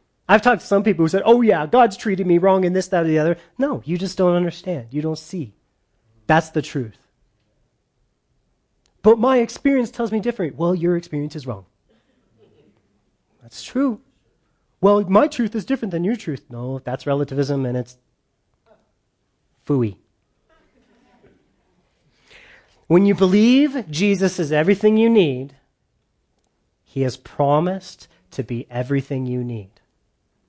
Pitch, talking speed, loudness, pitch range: 170 Hz, 145 wpm, -19 LUFS, 135-205 Hz